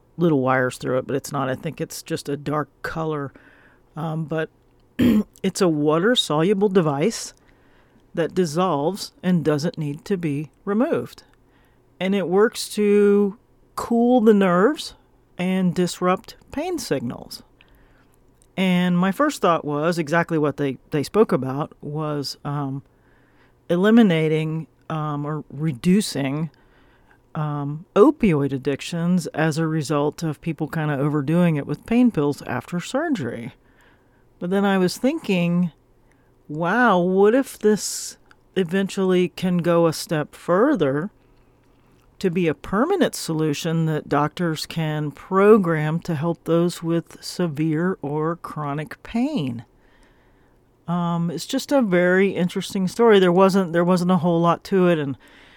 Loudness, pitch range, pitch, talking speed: -21 LUFS, 145-190 Hz, 165 Hz, 130 wpm